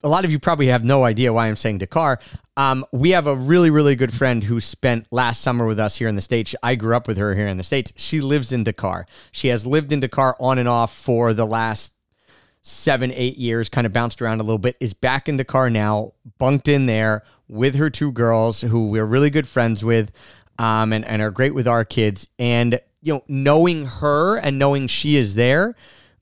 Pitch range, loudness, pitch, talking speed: 115-135 Hz, -19 LUFS, 125 Hz, 230 wpm